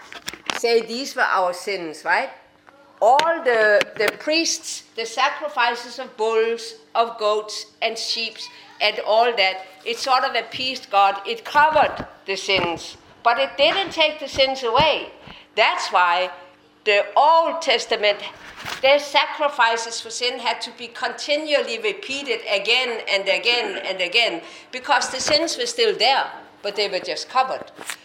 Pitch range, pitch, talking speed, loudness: 215-285 Hz, 235 Hz, 145 wpm, -20 LUFS